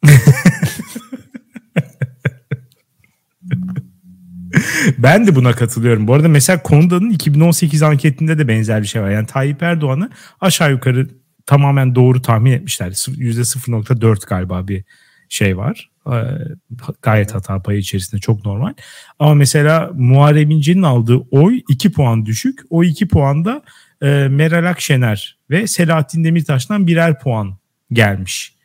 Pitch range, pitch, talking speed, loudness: 120-165 Hz, 140 Hz, 115 wpm, -14 LUFS